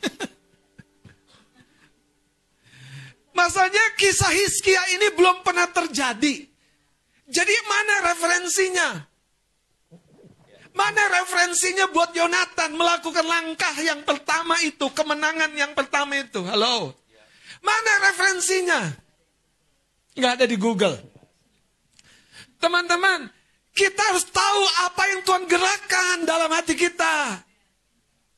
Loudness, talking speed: -20 LUFS, 85 wpm